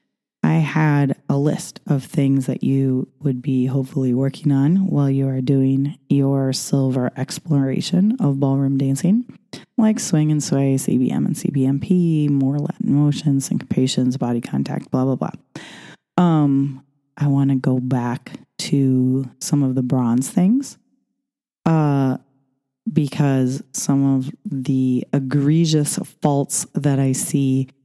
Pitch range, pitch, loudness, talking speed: 135-155 Hz, 140 Hz, -19 LUFS, 130 wpm